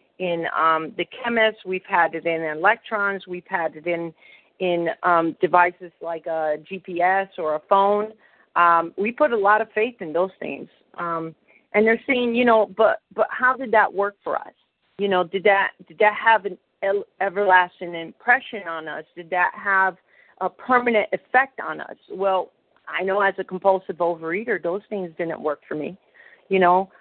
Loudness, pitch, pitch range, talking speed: -22 LUFS, 190 Hz, 175-210 Hz, 180 wpm